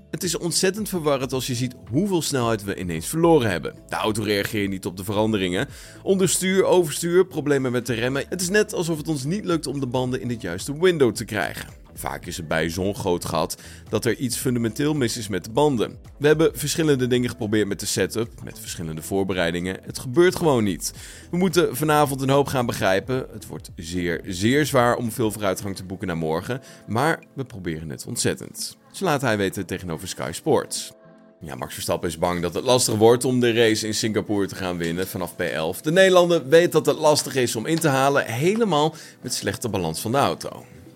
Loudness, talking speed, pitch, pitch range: -22 LUFS, 210 wpm, 120 Hz, 95-150 Hz